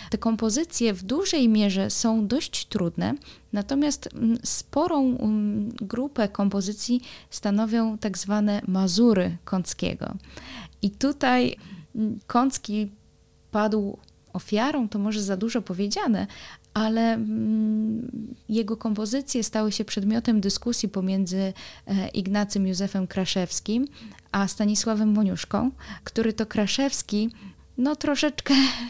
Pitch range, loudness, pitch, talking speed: 205-240 Hz, -25 LUFS, 220 Hz, 95 wpm